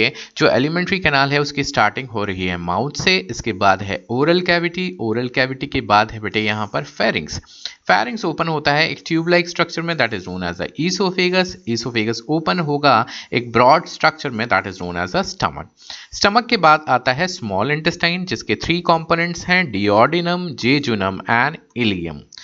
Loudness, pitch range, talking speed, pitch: -18 LUFS, 110-170 Hz, 180 wpm, 145 Hz